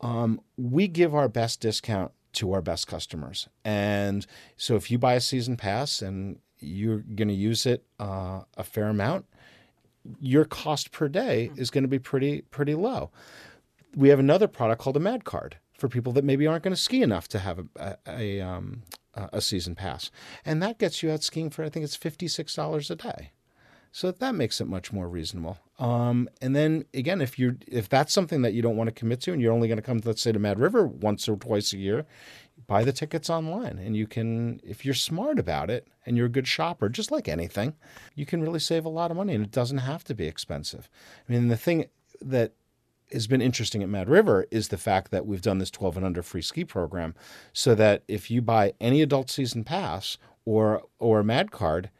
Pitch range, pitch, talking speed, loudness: 105-145 Hz, 120 Hz, 220 wpm, -27 LUFS